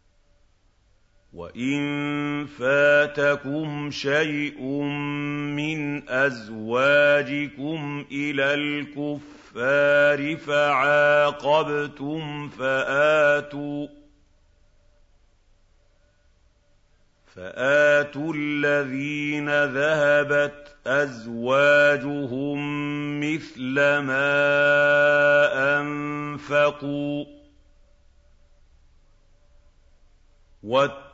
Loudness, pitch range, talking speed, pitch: -22 LUFS, 110-145 Hz, 35 wpm, 145 Hz